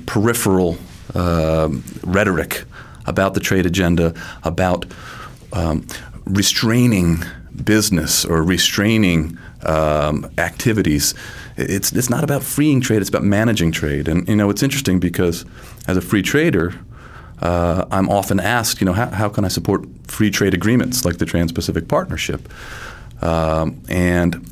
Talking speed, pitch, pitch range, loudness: 135 wpm, 90 Hz, 85-105 Hz, -18 LUFS